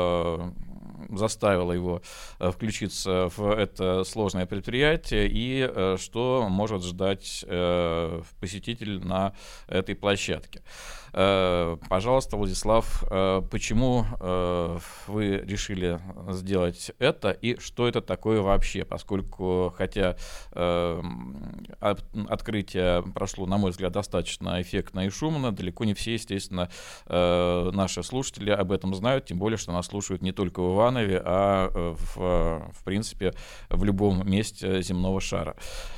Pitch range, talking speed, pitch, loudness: 90-105 Hz, 110 wpm, 95 Hz, -27 LUFS